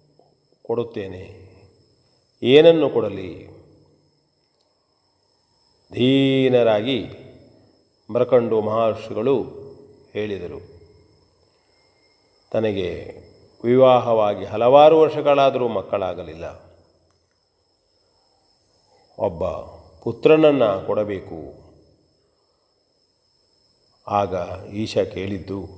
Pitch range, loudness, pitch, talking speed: 100-130 Hz, -19 LUFS, 115 Hz, 40 wpm